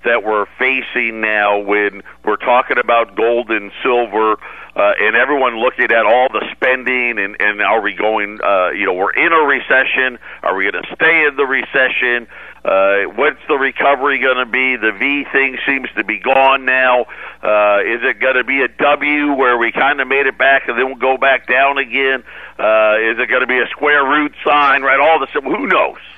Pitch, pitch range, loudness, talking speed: 125 Hz, 110-135 Hz, -13 LUFS, 210 wpm